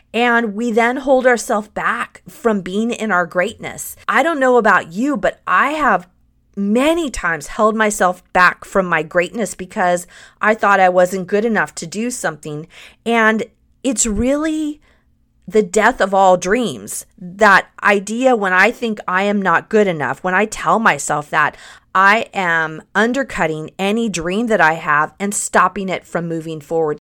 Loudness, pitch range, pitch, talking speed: -16 LUFS, 180-225 Hz, 200 Hz, 165 wpm